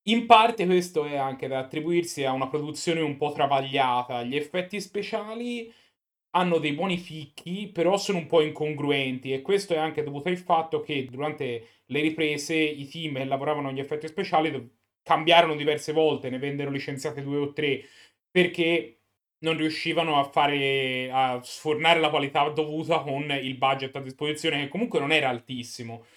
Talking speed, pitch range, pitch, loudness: 165 wpm, 135-165 Hz, 150 Hz, -26 LUFS